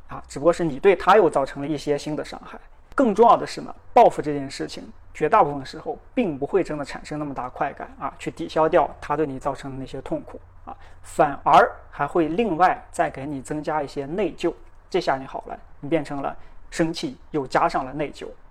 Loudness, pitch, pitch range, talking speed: -23 LUFS, 155 Hz, 145-170 Hz, 310 characters per minute